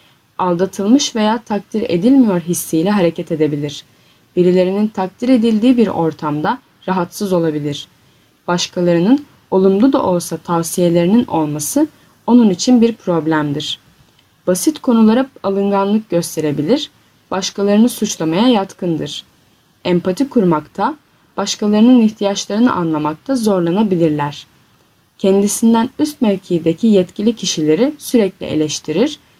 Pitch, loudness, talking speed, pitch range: 190 Hz, -15 LUFS, 90 wpm, 165-230 Hz